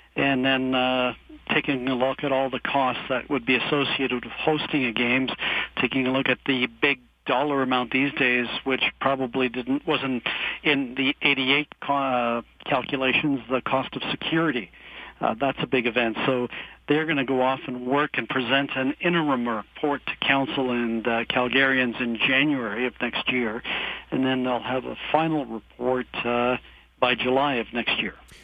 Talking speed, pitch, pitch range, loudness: 175 wpm, 130 Hz, 125-140 Hz, -24 LUFS